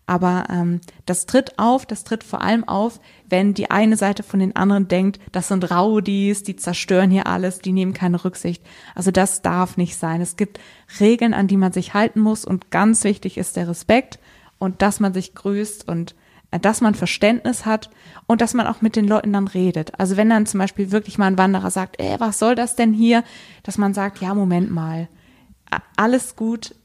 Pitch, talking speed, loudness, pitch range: 200 Hz, 205 wpm, -19 LUFS, 185-215 Hz